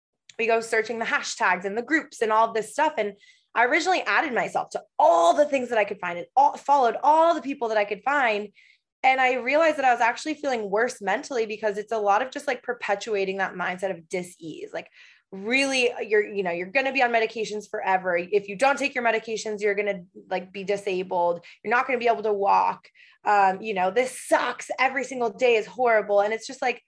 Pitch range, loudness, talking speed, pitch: 205-260 Hz, -24 LUFS, 225 wpm, 225 Hz